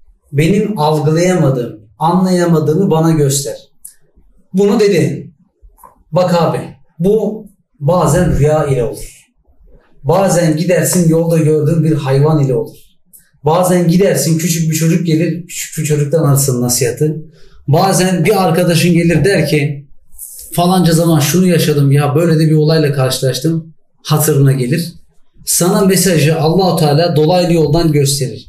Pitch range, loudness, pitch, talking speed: 150-175 Hz, -12 LUFS, 160 Hz, 120 wpm